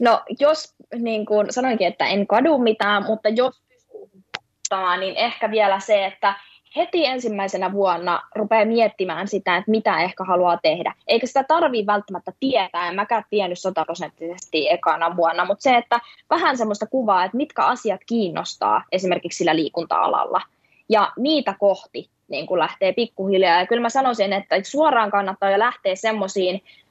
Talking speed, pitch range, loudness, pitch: 150 wpm, 185-235 Hz, -20 LUFS, 205 Hz